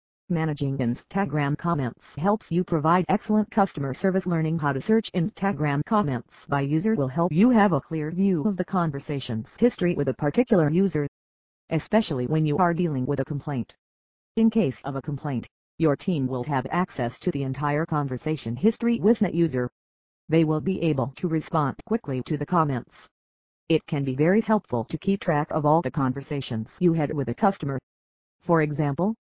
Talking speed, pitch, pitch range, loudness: 180 wpm, 155 Hz, 135-180 Hz, -25 LUFS